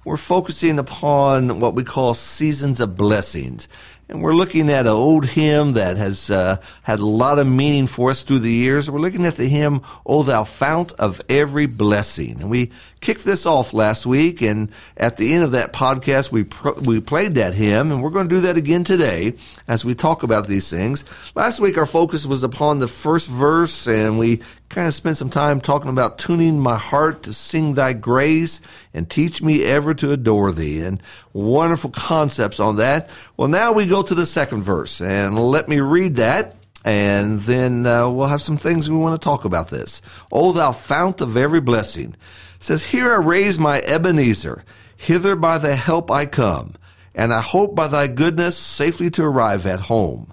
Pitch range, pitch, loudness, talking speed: 110-155 Hz, 135 Hz, -18 LUFS, 200 wpm